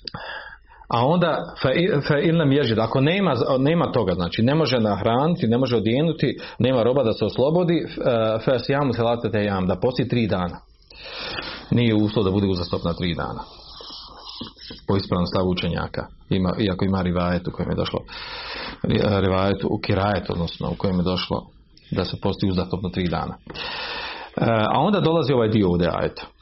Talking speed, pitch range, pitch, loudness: 150 wpm, 90-135 Hz, 105 Hz, -22 LUFS